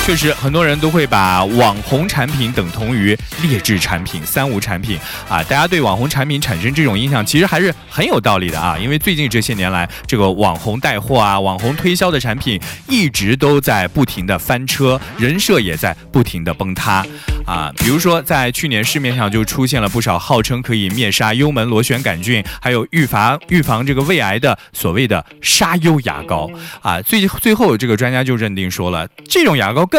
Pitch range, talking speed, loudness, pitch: 100-145 Hz, 300 characters per minute, -15 LUFS, 125 Hz